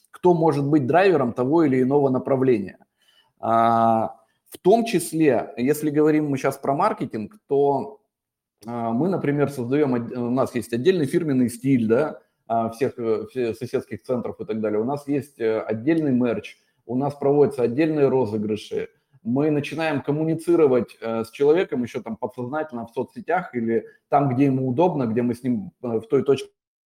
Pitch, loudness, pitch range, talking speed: 135 Hz, -22 LUFS, 115-150 Hz, 145 wpm